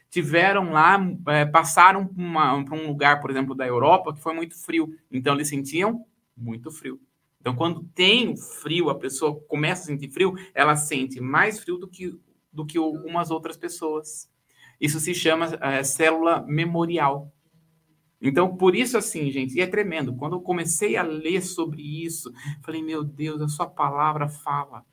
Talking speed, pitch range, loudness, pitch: 165 wpm, 145-175 Hz, -23 LUFS, 160 Hz